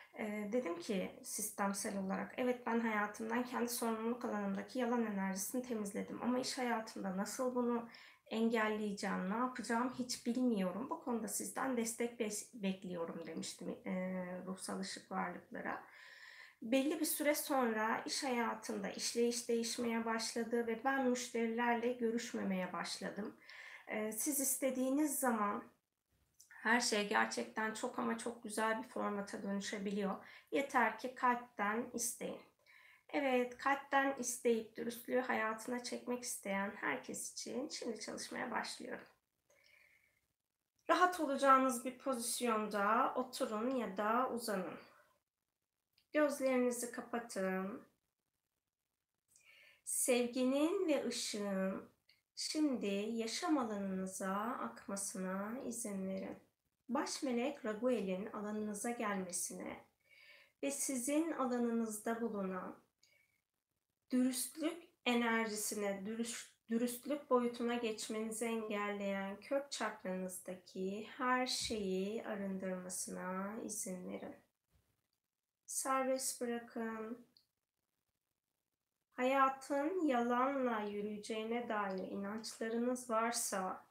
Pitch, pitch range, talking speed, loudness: 235 Hz, 210-255 Hz, 90 wpm, -39 LUFS